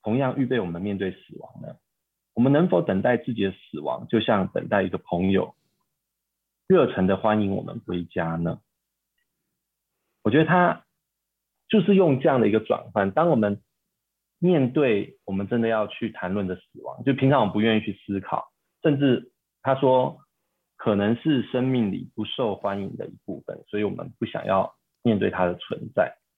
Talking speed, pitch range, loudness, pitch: 255 characters per minute, 100-135 Hz, -24 LUFS, 110 Hz